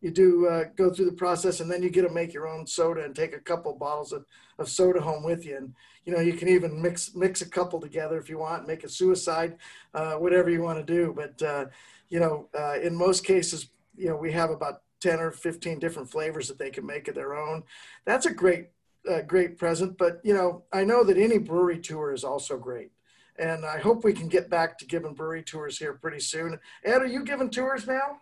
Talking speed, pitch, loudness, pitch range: 240 wpm, 170 Hz, -27 LUFS, 160-185 Hz